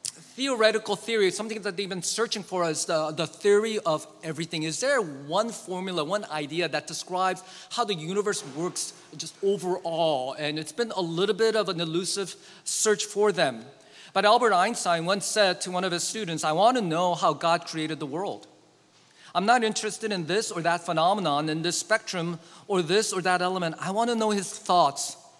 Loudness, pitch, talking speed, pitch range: -26 LUFS, 185 Hz, 190 wpm, 165-210 Hz